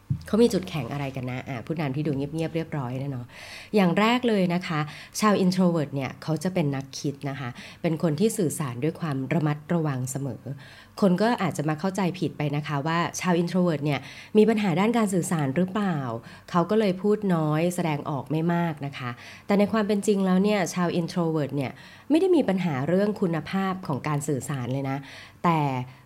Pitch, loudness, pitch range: 160 Hz, -26 LUFS, 140-185 Hz